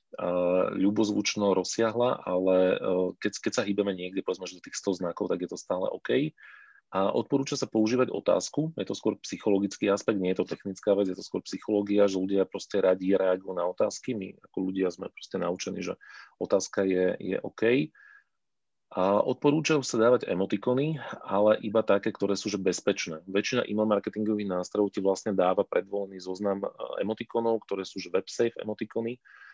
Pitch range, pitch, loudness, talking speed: 95-110 Hz, 100 Hz, -28 LUFS, 170 wpm